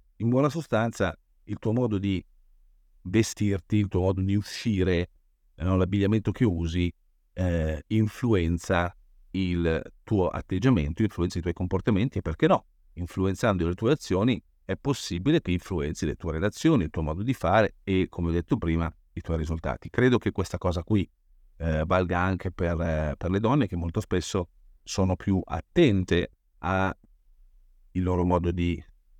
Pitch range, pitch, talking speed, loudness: 85-100 Hz, 90 Hz, 155 wpm, -27 LUFS